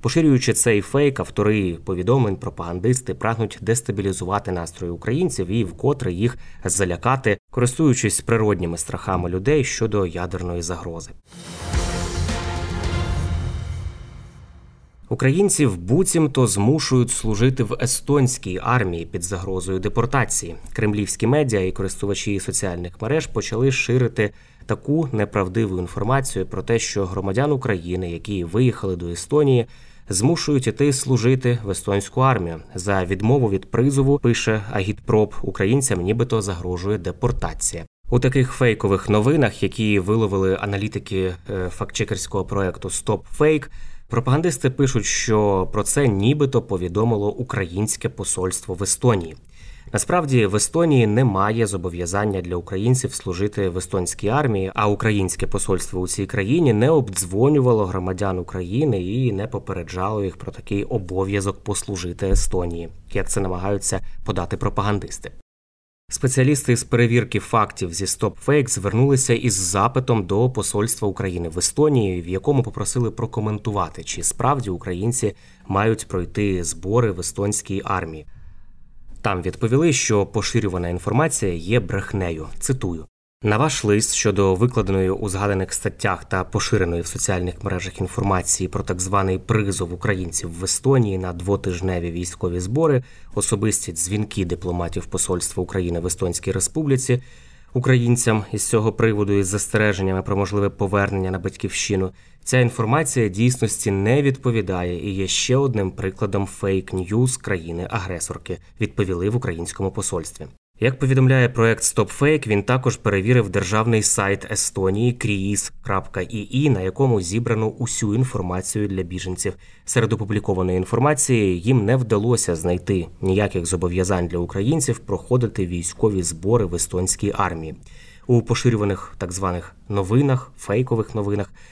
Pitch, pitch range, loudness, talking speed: 105 Hz, 95-120 Hz, -21 LUFS, 120 wpm